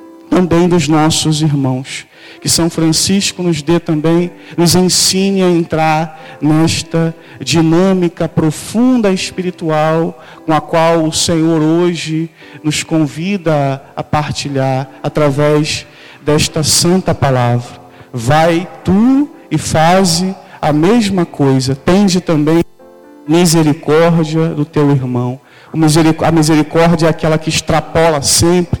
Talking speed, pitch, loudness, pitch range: 110 wpm, 160 Hz, -12 LUFS, 150-170 Hz